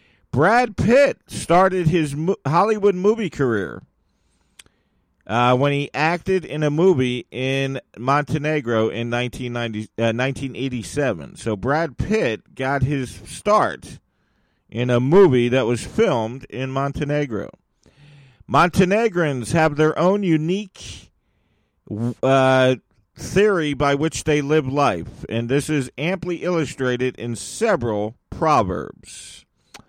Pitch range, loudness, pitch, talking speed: 120-165 Hz, -20 LUFS, 140 Hz, 105 wpm